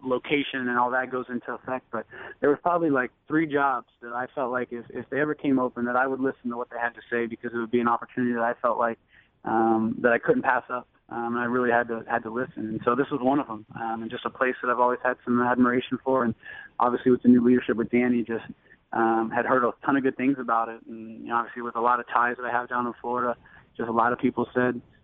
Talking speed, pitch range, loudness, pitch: 285 wpm, 115-125 Hz, -26 LUFS, 120 Hz